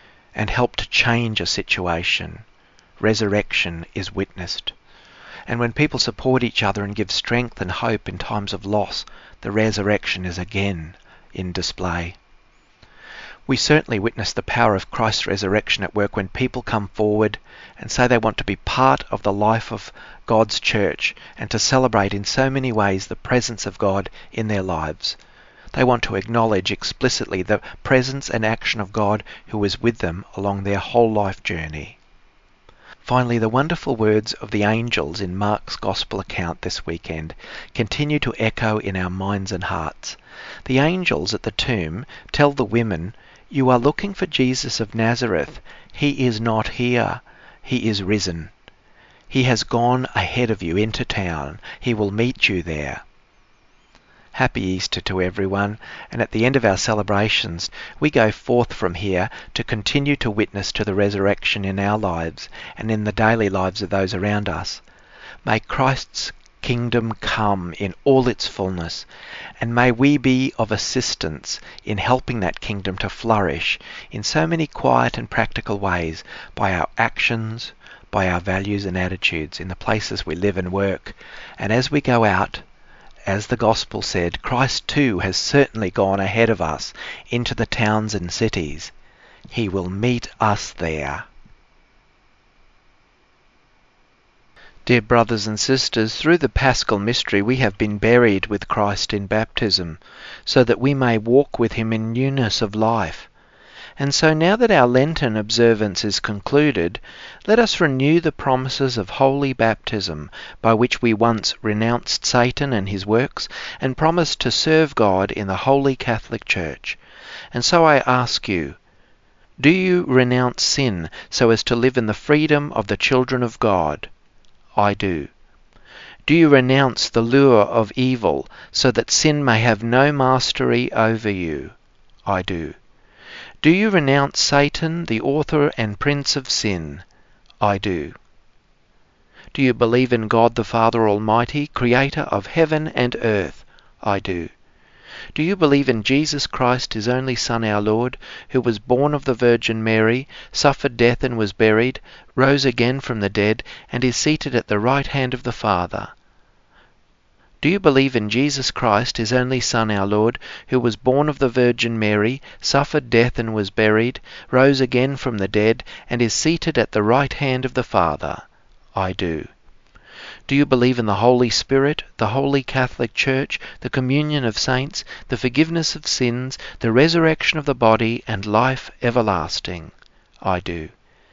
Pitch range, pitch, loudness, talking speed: 100-130 Hz, 115 Hz, -19 LUFS, 160 wpm